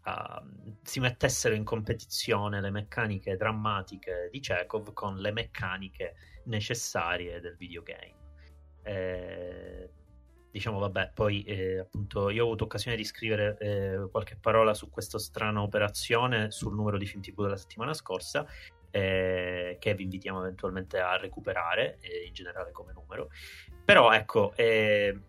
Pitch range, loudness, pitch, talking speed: 95-110 Hz, -30 LUFS, 105 Hz, 140 wpm